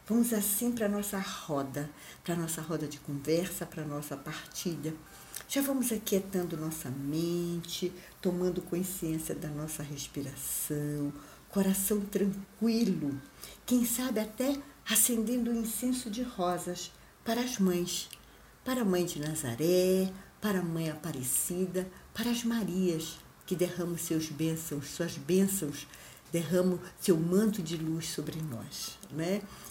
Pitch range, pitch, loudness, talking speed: 155-200 Hz, 175 Hz, -32 LUFS, 130 wpm